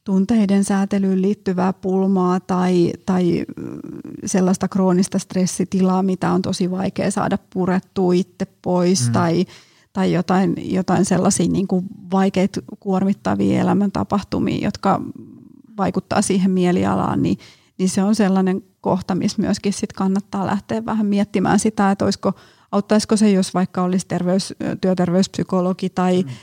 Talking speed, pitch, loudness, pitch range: 120 wpm, 190 Hz, -19 LUFS, 185-200 Hz